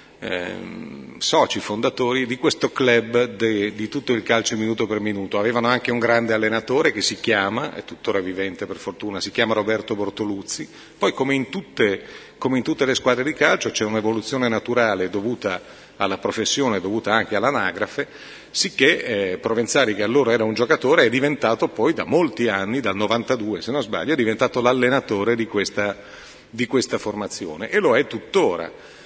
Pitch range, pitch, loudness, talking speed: 105-125 Hz, 115 Hz, -21 LUFS, 170 wpm